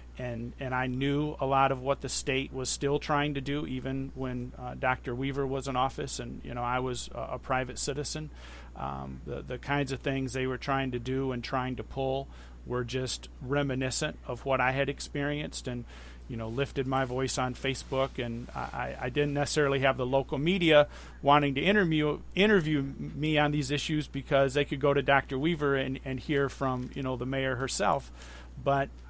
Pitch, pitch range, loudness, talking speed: 135 Hz, 125-145 Hz, -30 LUFS, 200 wpm